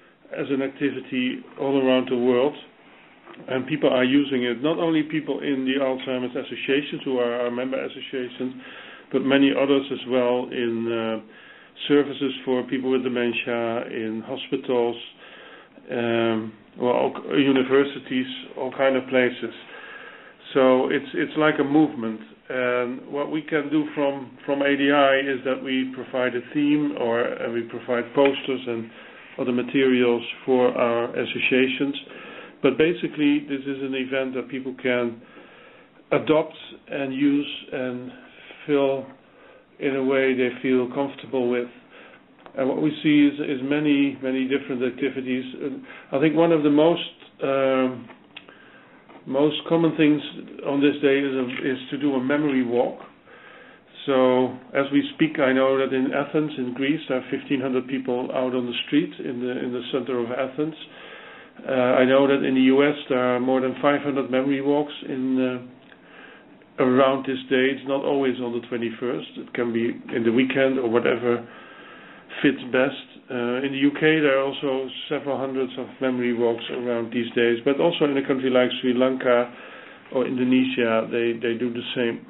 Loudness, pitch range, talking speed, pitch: -23 LUFS, 125-140 Hz, 165 wpm, 130 Hz